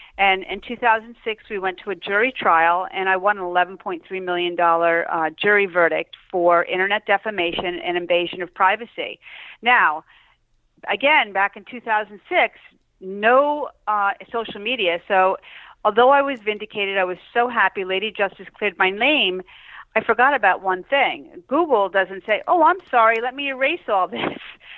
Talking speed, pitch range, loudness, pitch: 155 wpm, 185-240 Hz, -20 LUFS, 200 Hz